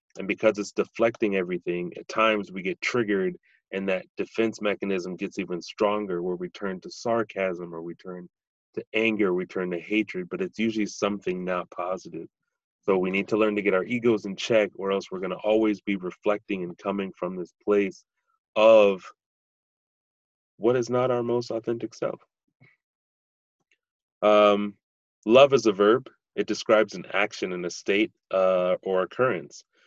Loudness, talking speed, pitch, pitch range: -25 LUFS, 170 wpm, 100 Hz, 90-110 Hz